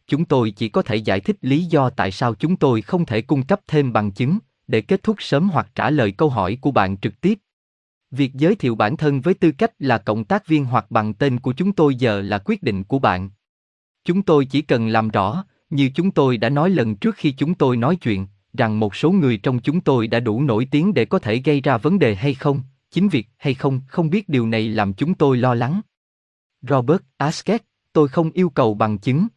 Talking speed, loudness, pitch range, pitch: 235 wpm, -19 LUFS, 110-160 Hz, 135 Hz